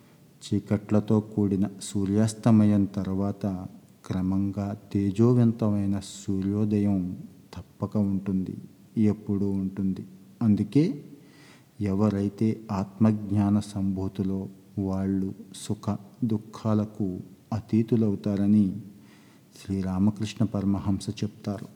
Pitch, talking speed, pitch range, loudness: 100 Hz, 60 wpm, 100-110 Hz, -27 LUFS